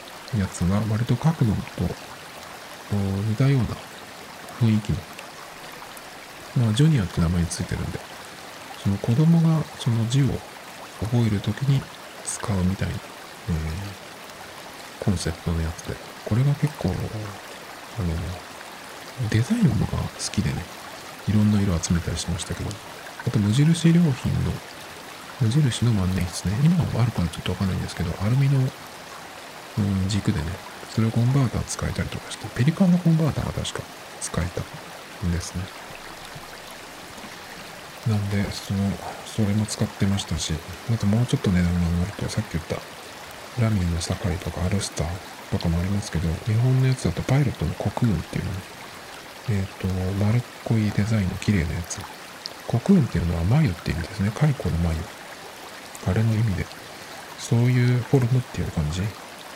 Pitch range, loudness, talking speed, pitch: 90-125 Hz, -24 LUFS, 320 characters per minute, 105 Hz